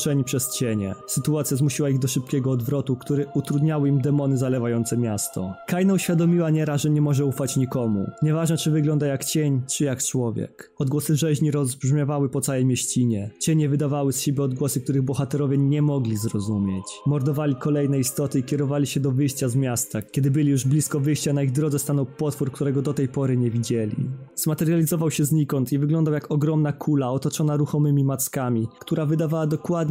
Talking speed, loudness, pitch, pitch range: 175 wpm, -23 LUFS, 145 Hz, 135-150 Hz